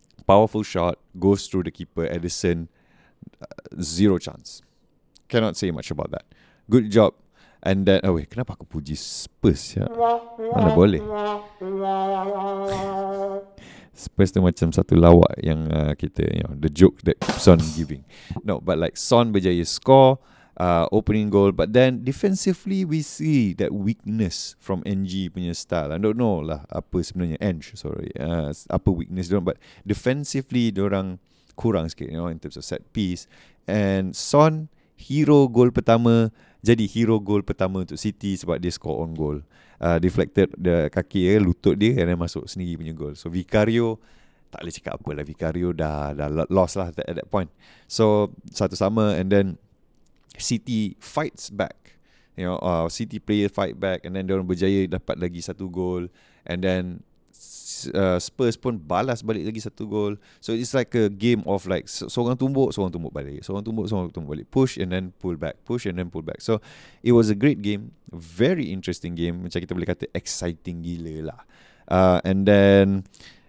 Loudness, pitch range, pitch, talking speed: -23 LUFS, 85-110 Hz, 95 Hz, 175 wpm